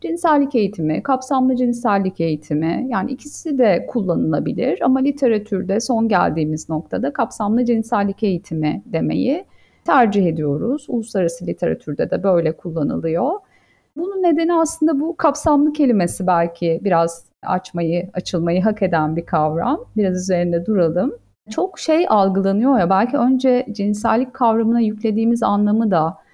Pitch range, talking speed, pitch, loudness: 175-260 Hz, 120 wpm, 210 Hz, -19 LUFS